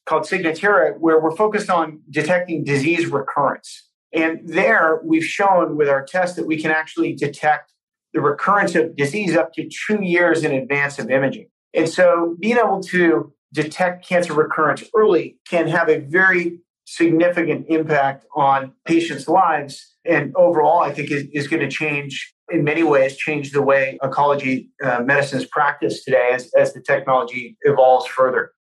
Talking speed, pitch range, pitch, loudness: 160 wpm, 140-170 Hz, 160 Hz, -18 LUFS